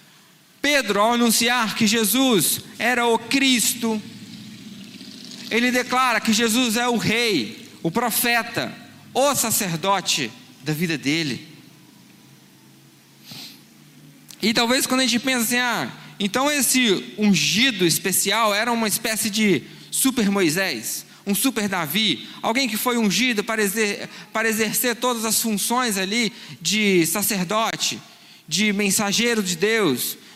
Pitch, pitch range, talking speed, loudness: 220 Hz, 200-240 Hz, 120 wpm, -20 LUFS